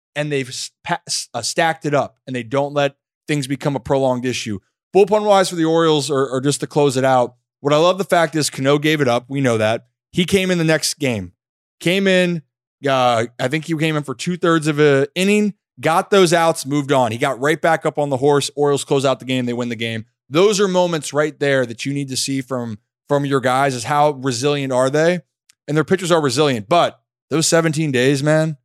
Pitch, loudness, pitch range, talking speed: 145 Hz, -18 LUFS, 130-160 Hz, 230 wpm